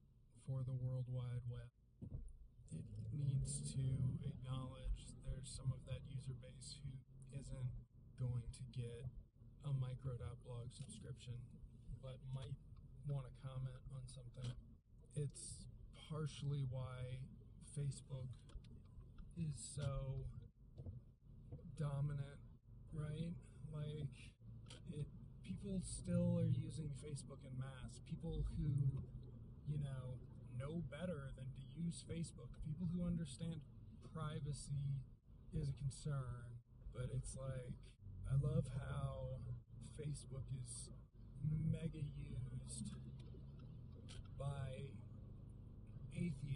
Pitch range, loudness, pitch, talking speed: 120-140 Hz, -48 LUFS, 130 Hz, 100 wpm